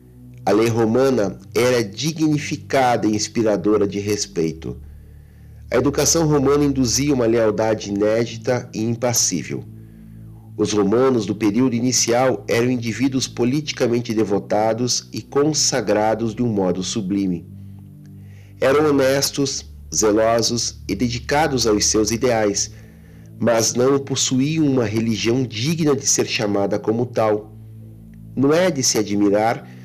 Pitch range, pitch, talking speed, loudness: 105-130 Hz, 115 Hz, 115 wpm, -19 LUFS